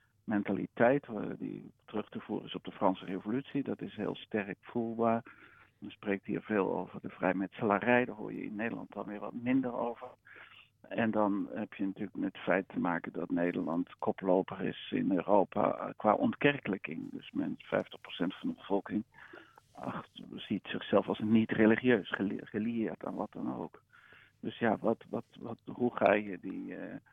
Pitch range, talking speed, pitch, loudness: 100-120 Hz, 165 wpm, 110 Hz, -34 LUFS